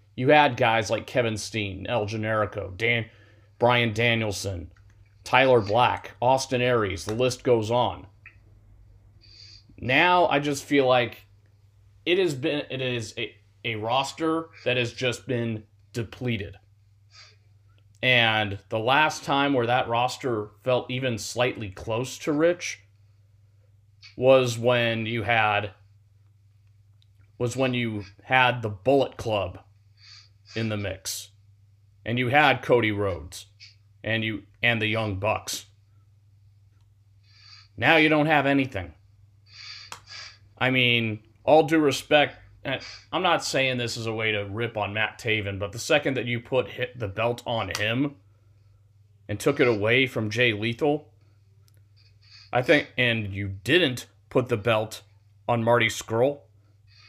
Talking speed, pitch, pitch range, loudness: 130 wpm, 110 Hz, 100-125 Hz, -24 LUFS